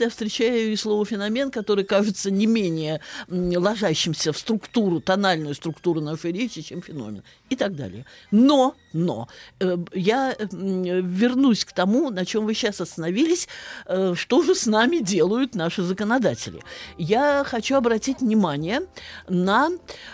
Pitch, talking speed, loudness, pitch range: 205 Hz, 130 wpm, -22 LUFS, 180-240 Hz